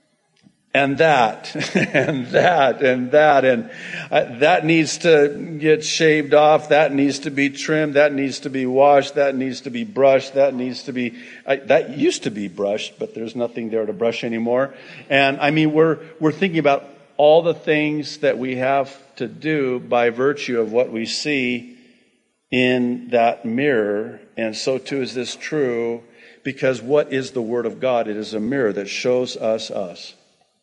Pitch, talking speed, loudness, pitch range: 135 Hz, 180 wpm, -19 LUFS, 120-150 Hz